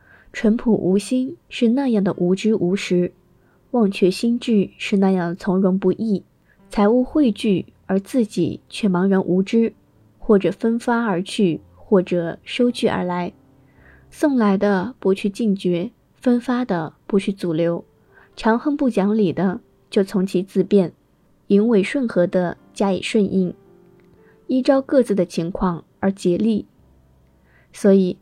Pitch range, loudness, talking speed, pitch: 180-225 Hz, -20 LUFS, 200 characters per minute, 195 Hz